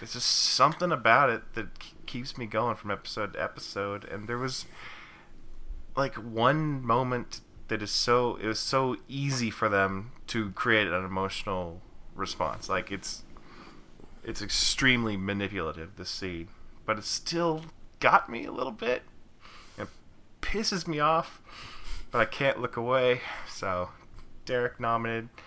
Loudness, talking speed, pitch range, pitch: -29 LUFS, 140 wpm, 100-125 Hz, 115 Hz